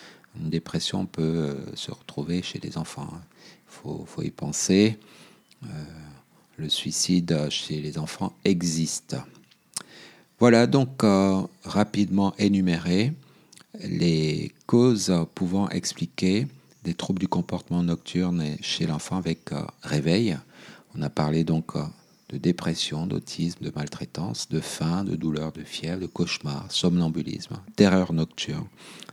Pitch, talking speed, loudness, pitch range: 85 Hz, 115 wpm, -26 LUFS, 80-100 Hz